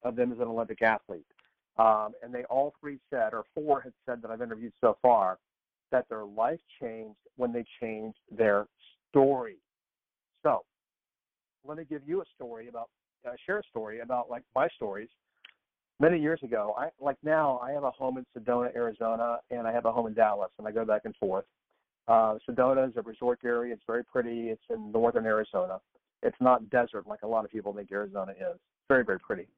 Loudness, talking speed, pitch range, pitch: -30 LUFS, 200 wpm, 115-130 Hz, 120 Hz